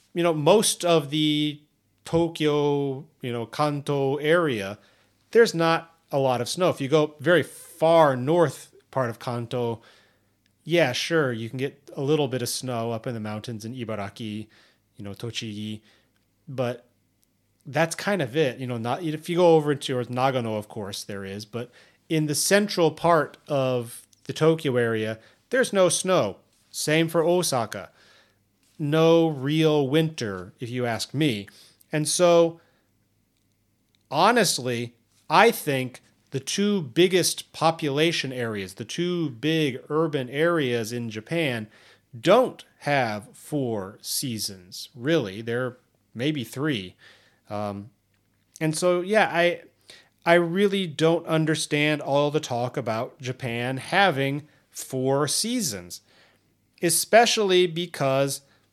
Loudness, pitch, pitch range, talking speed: -24 LUFS, 135 Hz, 115-160 Hz, 130 wpm